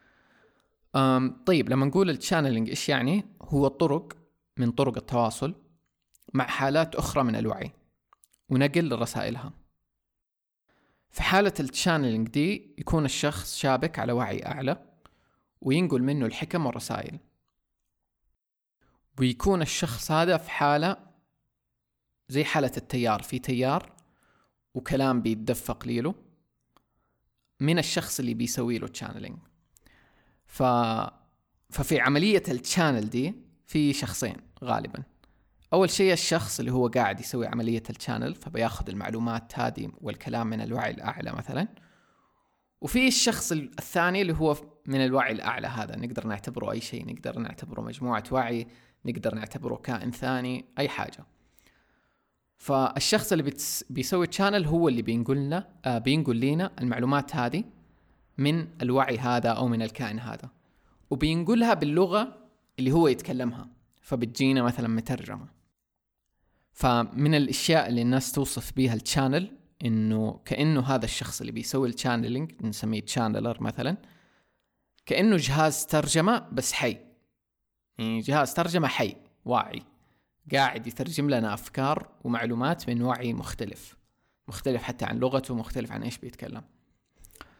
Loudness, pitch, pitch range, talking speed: -27 LUFS, 130 Hz, 120-155 Hz, 115 wpm